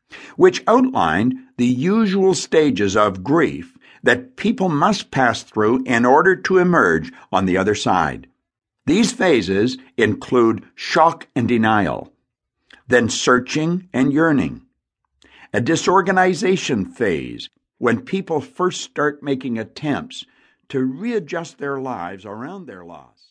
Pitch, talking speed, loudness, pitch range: 155 Hz, 120 wpm, -18 LUFS, 125-195 Hz